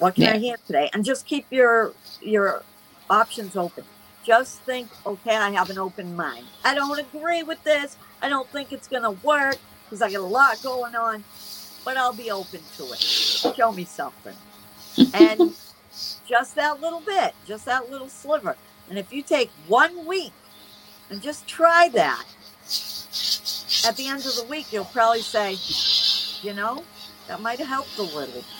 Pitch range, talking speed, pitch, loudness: 205-285 Hz, 175 wpm, 240 Hz, -22 LUFS